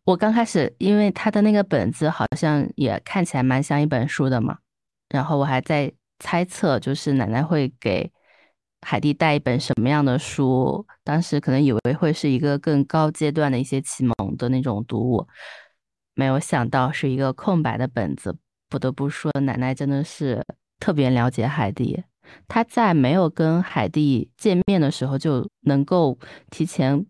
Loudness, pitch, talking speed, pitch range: -22 LUFS, 140 Hz, 255 characters per minute, 130-160 Hz